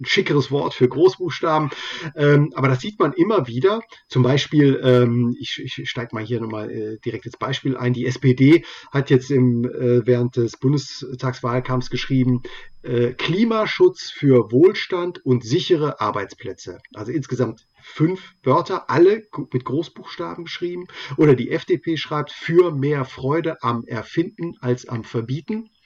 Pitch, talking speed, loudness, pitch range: 135 Hz, 130 wpm, -20 LUFS, 125-165 Hz